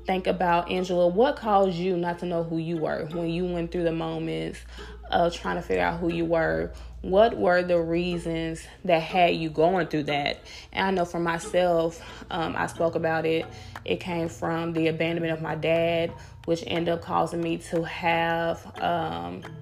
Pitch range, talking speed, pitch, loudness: 160-175 Hz, 190 wpm, 165 Hz, -26 LUFS